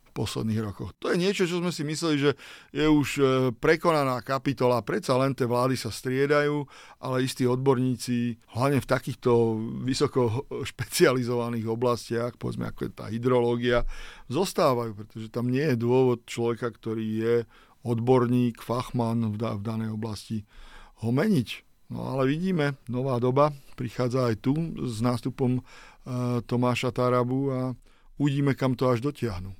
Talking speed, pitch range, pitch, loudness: 140 wpm, 115-135 Hz, 125 Hz, -27 LUFS